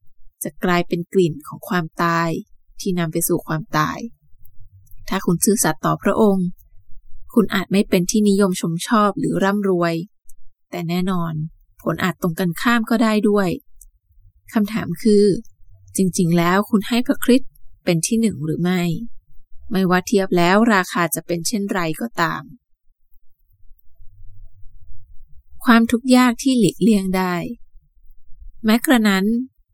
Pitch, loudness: 180 Hz, -19 LUFS